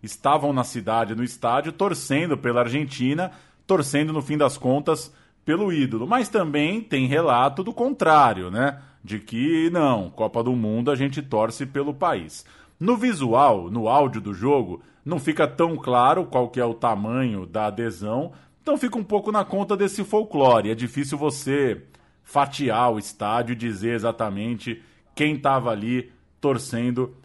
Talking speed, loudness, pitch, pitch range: 155 wpm, -23 LUFS, 135 Hz, 115-155 Hz